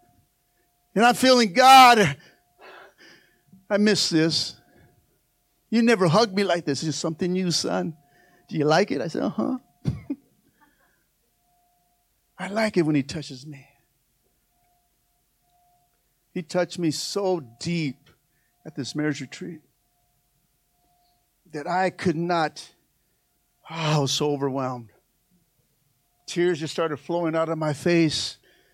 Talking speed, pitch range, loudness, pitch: 125 wpm, 140-180 Hz, -22 LUFS, 165 Hz